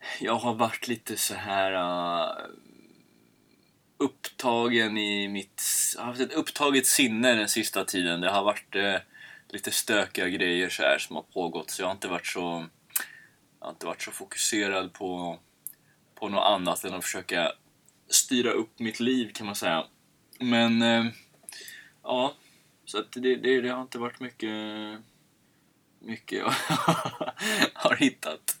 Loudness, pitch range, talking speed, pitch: -27 LUFS, 100-125 Hz, 155 wpm, 115 Hz